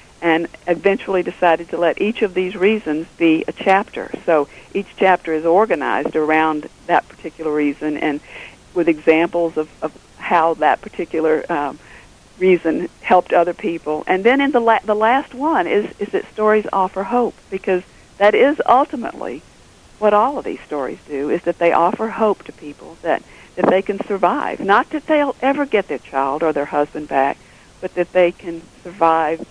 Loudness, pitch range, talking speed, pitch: -18 LUFS, 160-205 Hz, 175 wpm, 175 Hz